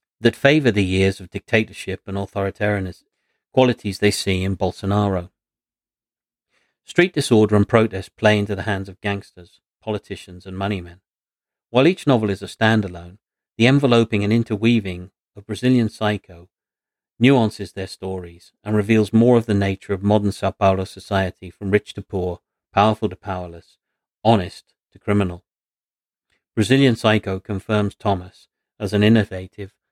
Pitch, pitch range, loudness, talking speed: 100 Hz, 95-110 Hz, -20 LUFS, 140 wpm